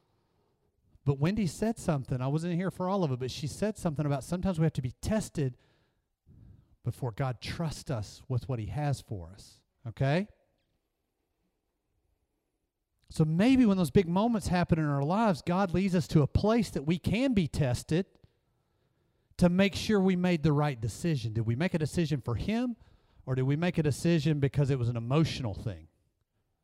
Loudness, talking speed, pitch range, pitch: -30 LUFS, 180 wpm, 130-180 Hz, 155 Hz